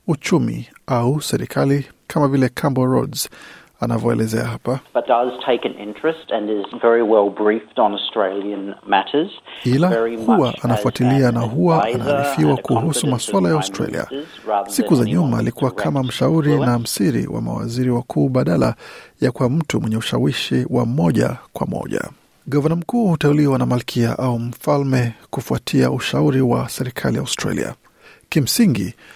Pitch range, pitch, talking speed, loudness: 115-140 Hz, 125 Hz, 110 wpm, -19 LUFS